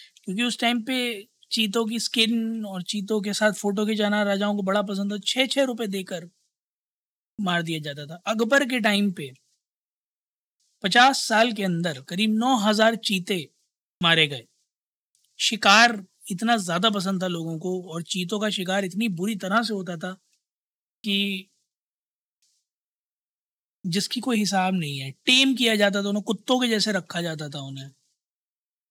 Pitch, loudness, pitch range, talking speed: 205 Hz, -23 LUFS, 185-225 Hz, 155 wpm